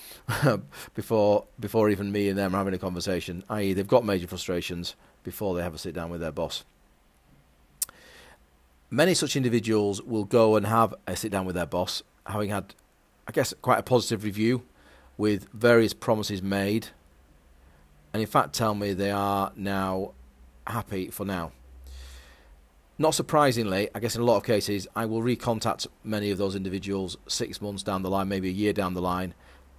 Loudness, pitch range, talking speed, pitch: -27 LUFS, 85-110 Hz, 175 wpm, 100 Hz